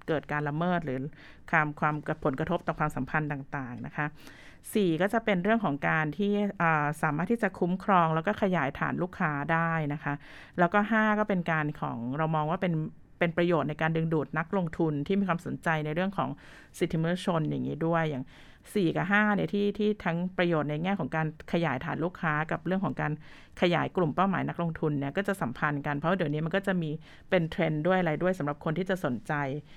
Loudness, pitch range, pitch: -29 LUFS, 150-185 Hz, 165 Hz